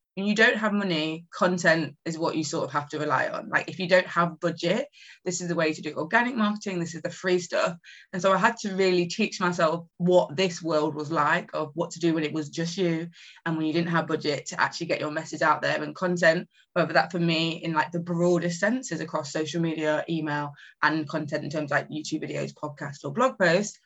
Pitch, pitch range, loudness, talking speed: 170 Hz, 155-185 Hz, -26 LUFS, 240 wpm